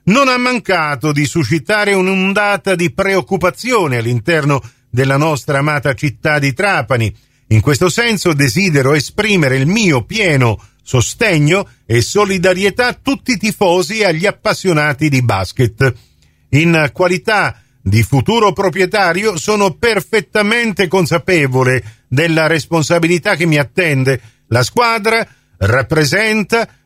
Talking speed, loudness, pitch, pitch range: 115 wpm, -13 LUFS, 165 Hz, 135-200 Hz